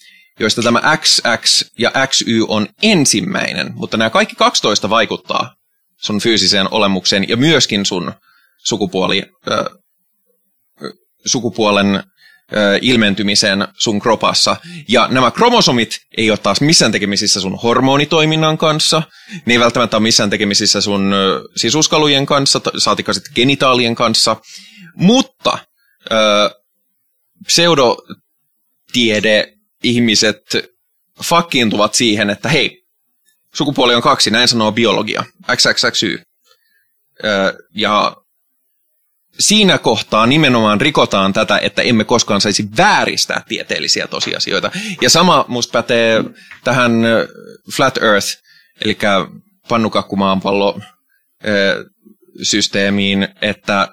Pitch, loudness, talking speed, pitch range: 115 Hz, -13 LUFS, 100 wpm, 105-155 Hz